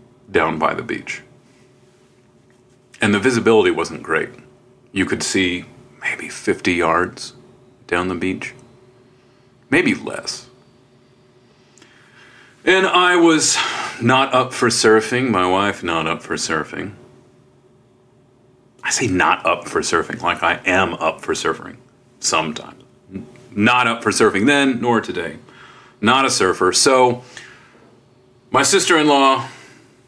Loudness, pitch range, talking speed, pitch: -17 LUFS, 115-130 Hz, 120 wpm, 125 Hz